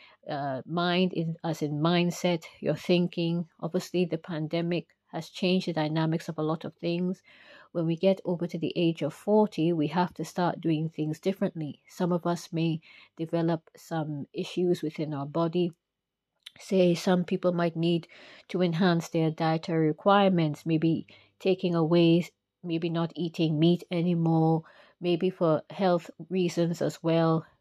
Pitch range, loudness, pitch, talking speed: 160-175 Hz, -28 LUFS, 170 Hz, 150 wpm